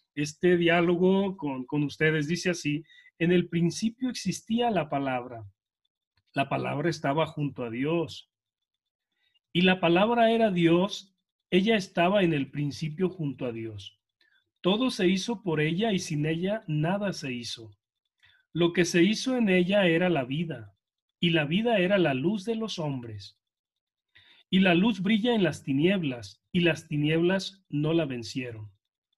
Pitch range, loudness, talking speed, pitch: 130-185 Hz, -27 LUFS, 150 wpm, 165 Hz